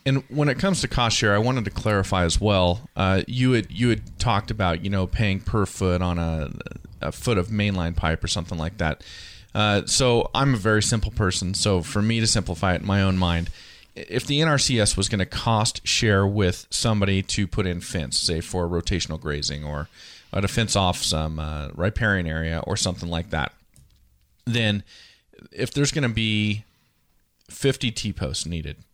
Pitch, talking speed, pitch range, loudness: 100 Hz, 195 wpm, 85-110 Hz, -23 LUFS